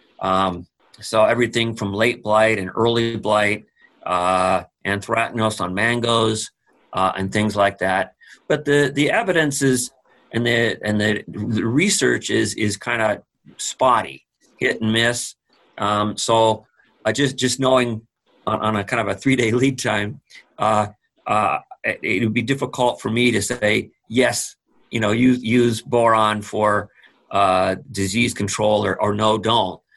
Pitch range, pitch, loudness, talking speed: 105-120 Hz, 110 Hz, -20 LUFS, 155 wpm